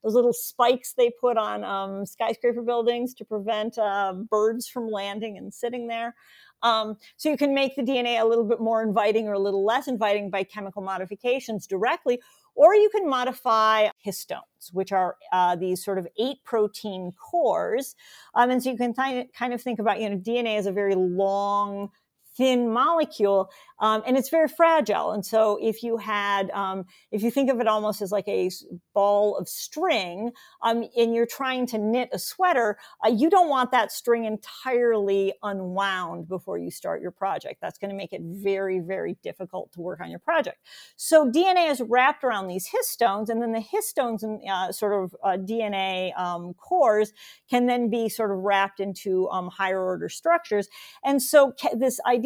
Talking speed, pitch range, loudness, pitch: 190 wpm, 195-250 Hz, -25 LUFS, 220 Hz